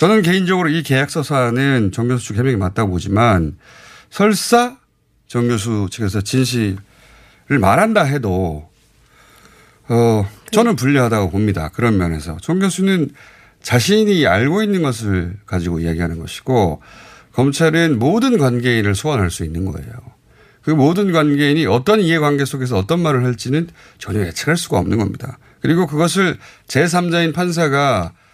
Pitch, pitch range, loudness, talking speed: 130 Hz, 105-165 Hz, -16 LUFS, 310 characters per minute